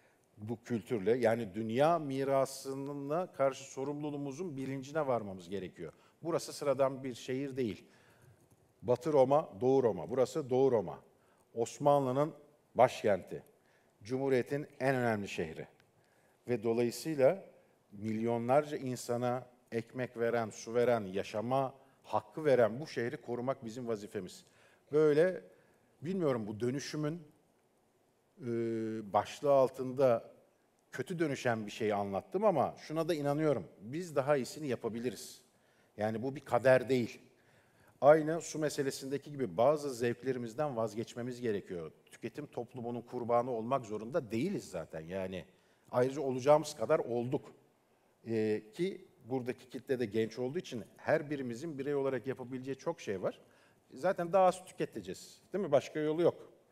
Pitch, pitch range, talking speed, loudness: 130 Hz, 115-145 Hz, 120 wpm, -34 LUFS